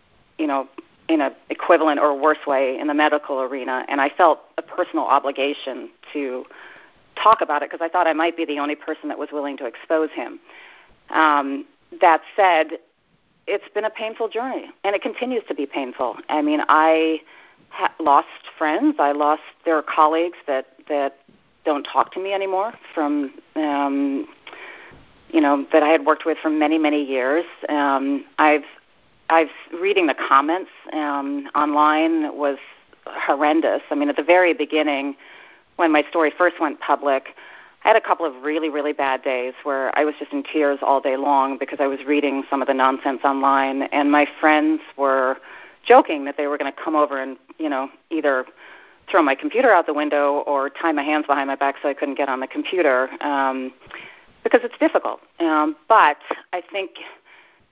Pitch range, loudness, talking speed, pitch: 140-165 Hz, -20 LUFS, 185 wpm, 150 Hz